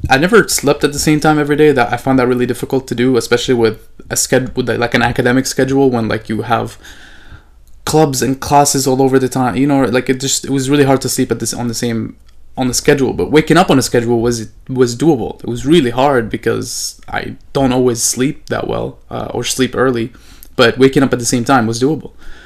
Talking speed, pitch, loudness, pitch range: 240 wpm, 130 Hz, -13 LUFS, 120-135 Hz